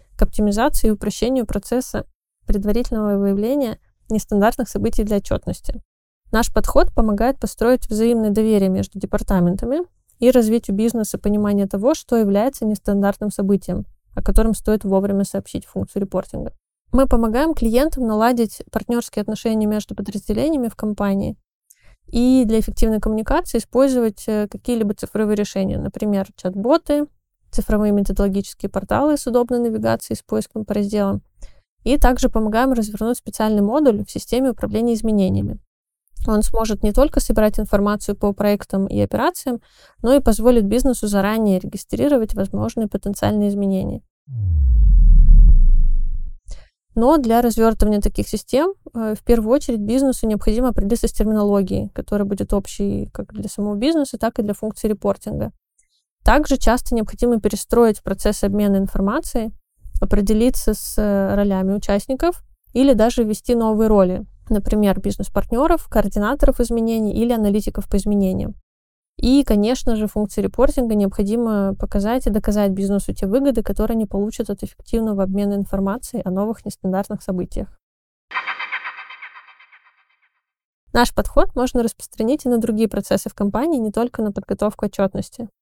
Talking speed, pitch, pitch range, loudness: 125 wpm, 215 Hz, 200-240 Hz, -19 LUFS